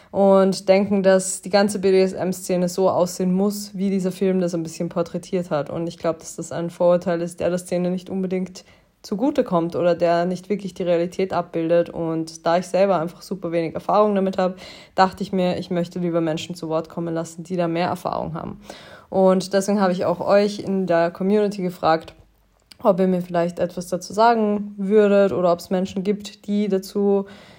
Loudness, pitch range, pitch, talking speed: -21 LUFS, 170-195 Hz, 185 Hz, 195 wpm